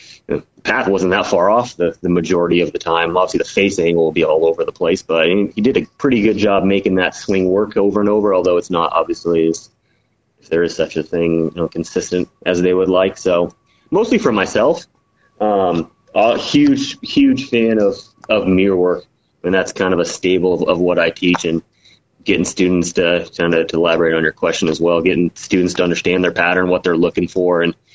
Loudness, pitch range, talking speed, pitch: -16 LUFS, 85-105 Hz, 225 wpm, 90 Hz